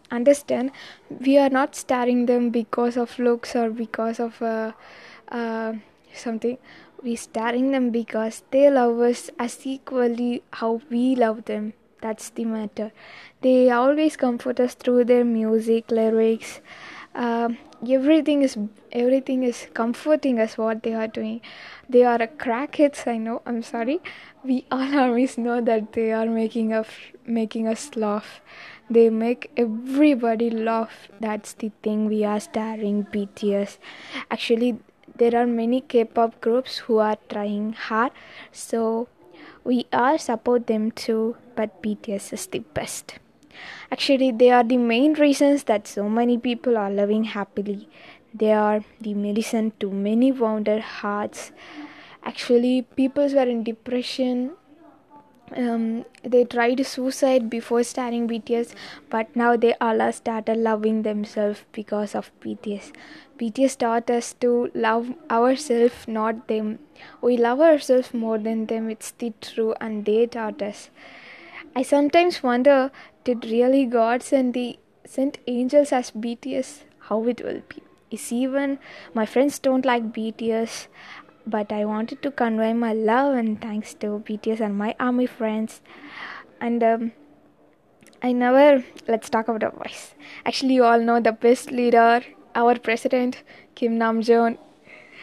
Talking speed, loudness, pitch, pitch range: 140 wpm, -22 LUFS, 235 Hz, 225-255 Hz